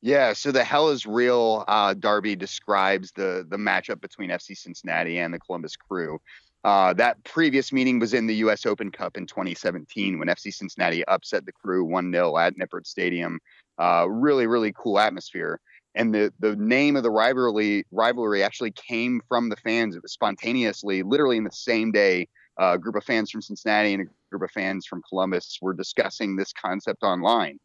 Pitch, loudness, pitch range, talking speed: 105 Hz, -24 LUFS, 95-115 Hz, 185 wpm